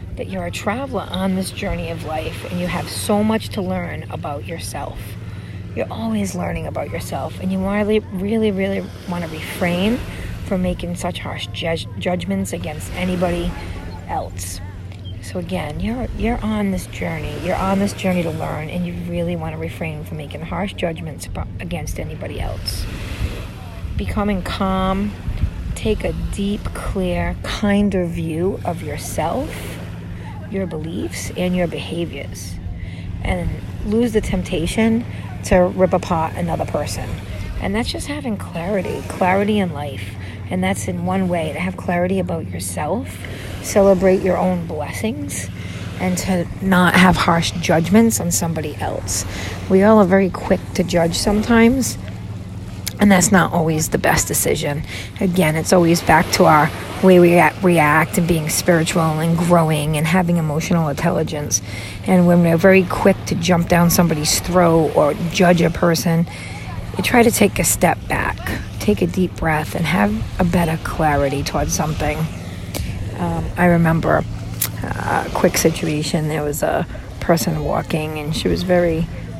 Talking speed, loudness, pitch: 150 wpm, -19 LUFS, 150 Hz